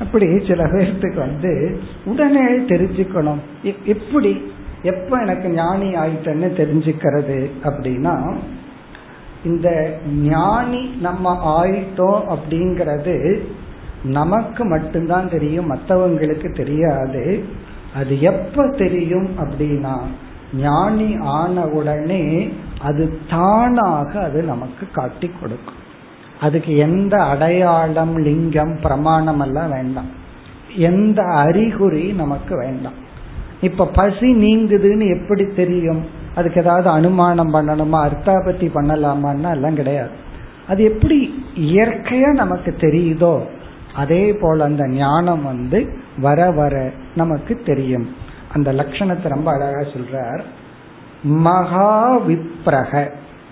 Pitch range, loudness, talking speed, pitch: 145-185 Hz, -17 LUFS, 90 wpm, 165 Hz